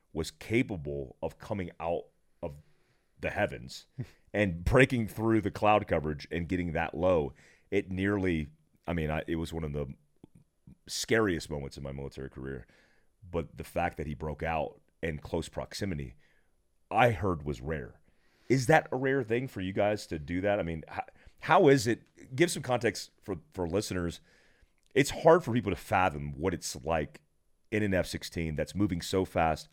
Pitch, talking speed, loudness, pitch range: 85 Hz, 175 wpm, -31 LUFS, 80-105 Hz